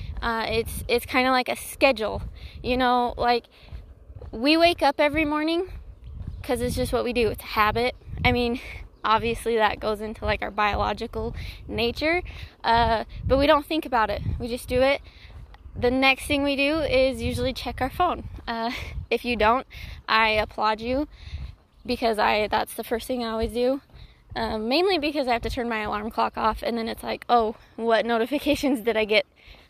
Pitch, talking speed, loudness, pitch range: 240 Hz, 185 wpm, -24 LUFS, 225-275 Hz